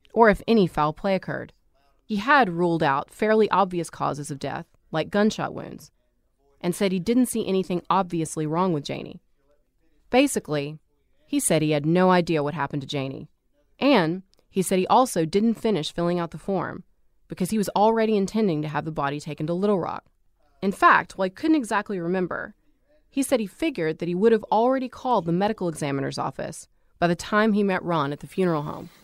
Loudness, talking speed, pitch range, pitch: -24 LUFS, 195 wpm, 155-215 Hz, 180 Hz